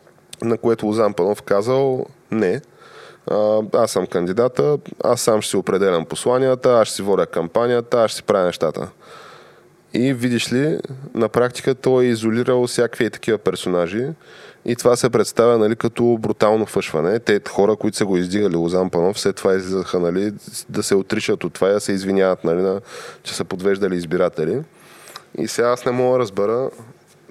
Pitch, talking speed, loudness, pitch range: 115 Hz, 170 wpm, -19 LUFS, 100-125 Hz